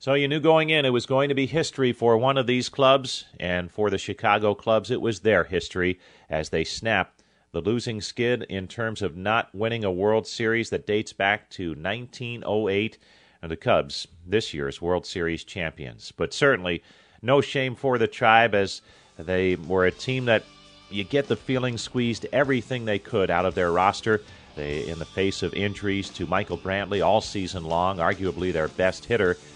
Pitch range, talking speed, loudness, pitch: 95-120 Hz, 195 wpm, -25 LUFS, 105 Hz